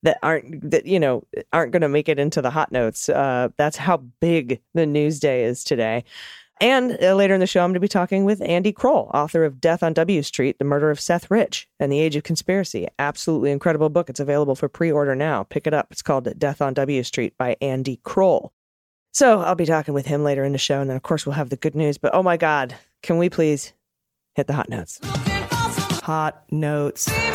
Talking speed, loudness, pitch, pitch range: 235 wpm, -21 LUFS, 155 Hz, 140-175 Hz